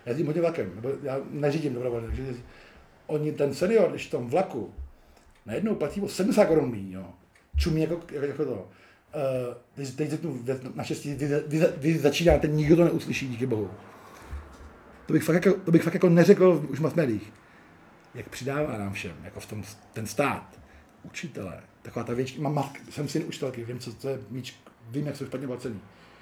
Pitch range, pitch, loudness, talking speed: 110-155 Hz, 135 Hz, -27 LUFS, 175 wpm